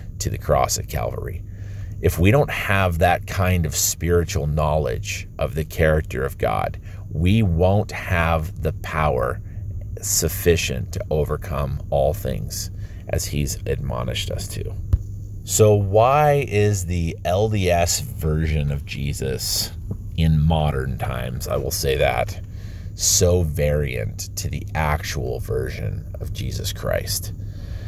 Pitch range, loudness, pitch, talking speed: 80-100 Hz, -22 LUFS, 95 Hz, 125 wpm